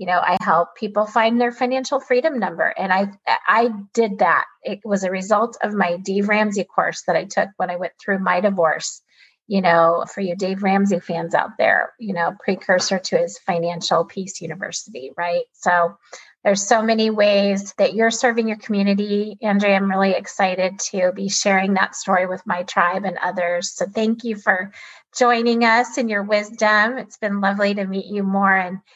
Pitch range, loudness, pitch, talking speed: 185-220 Hz, -19 LUFS, 200 Hz, 190 wpm